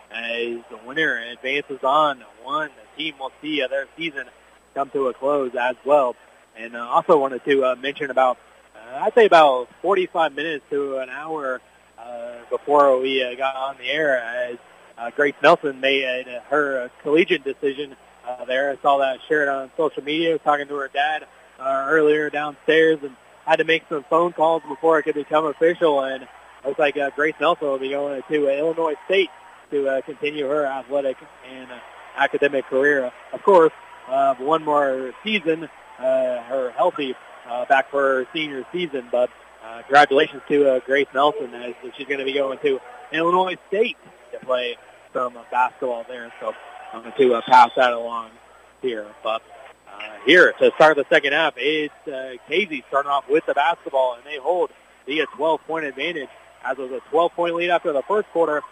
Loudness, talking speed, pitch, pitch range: -21 LUFS, 185 wpm, 140 Hz, 130-160 Hz